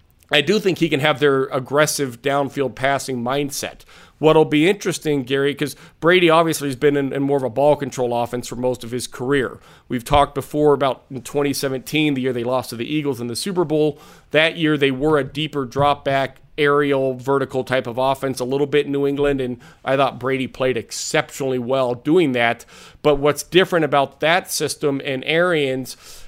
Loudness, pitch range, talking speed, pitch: -19 LUFS, 130-150 Hz, 195 wpm, 140 Hz